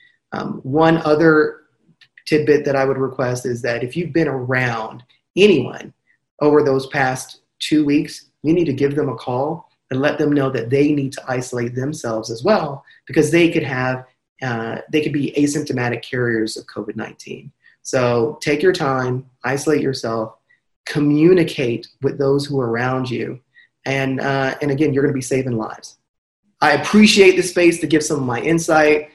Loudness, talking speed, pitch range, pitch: -18 LUFS, 175 wpm, 125-155 Hz, 140 Hz